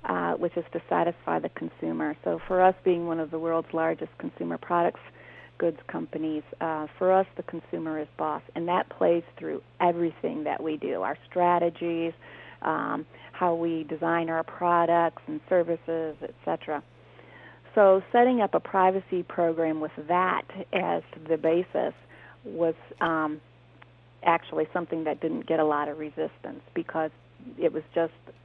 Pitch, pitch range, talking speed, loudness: 165 Hz, 155-175 Hz, 150 wpm, -28 LUFS